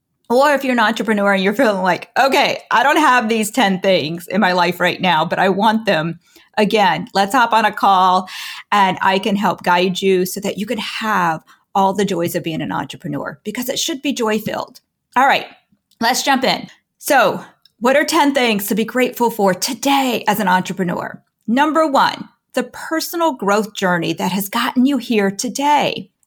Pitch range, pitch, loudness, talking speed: 185-245 Hz, 210 Hz, -16 LUFS, 195 wpm